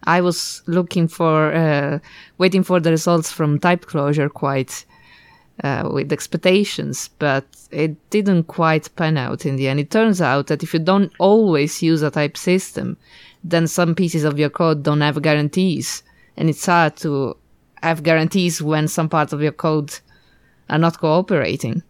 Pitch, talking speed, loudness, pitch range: 160 Hz, 165 wpm, -18 LUFS, 150-175 Hz